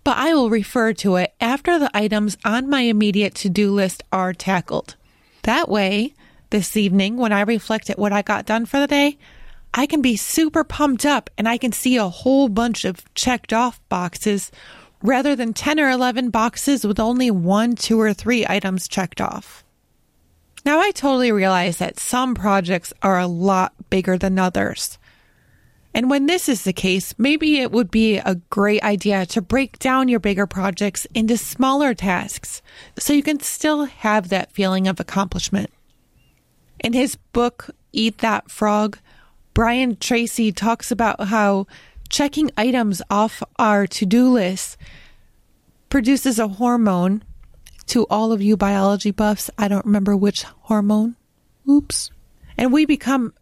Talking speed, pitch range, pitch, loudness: 160 wpm, 200-250 Hz, 220 Hz, -19 LUFS